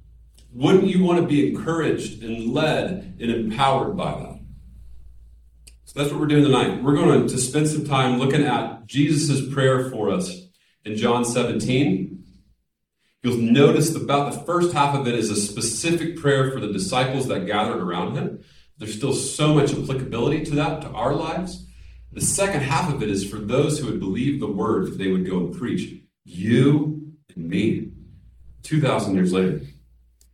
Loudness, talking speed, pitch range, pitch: -22 LUFS, 170 wpm, 110-150 Hz, 135 Hz